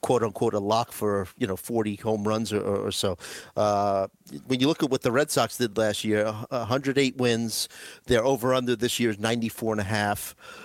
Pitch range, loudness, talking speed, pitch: 105-125 Hz, -26 LUFS, 205 wpm, 115 Hz